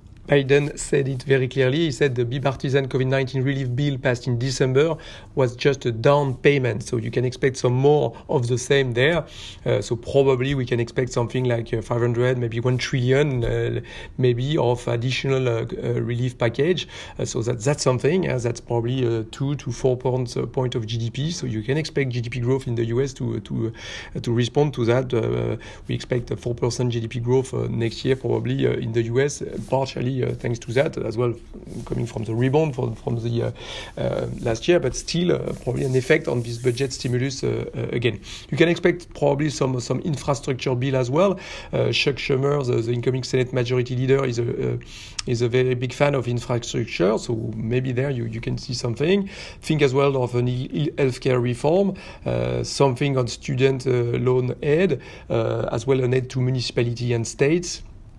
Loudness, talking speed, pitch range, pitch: -23 LUFS, 195 wpm, 120-140 Hz, 125 Hz